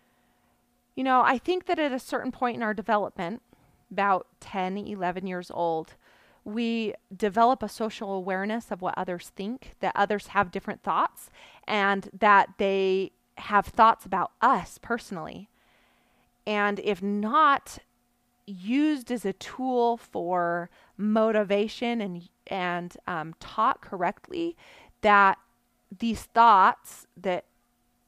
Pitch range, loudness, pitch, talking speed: 195-235 Hz, -26 LUFS, 210 Hz, 120 wpm